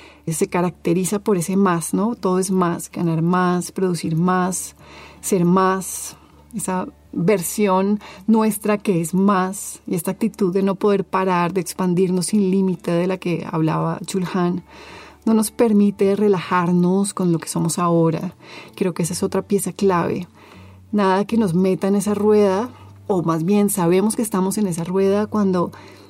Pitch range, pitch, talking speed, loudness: 175-200 Hz, 185 Hz, 160 wpm, -20 LUFS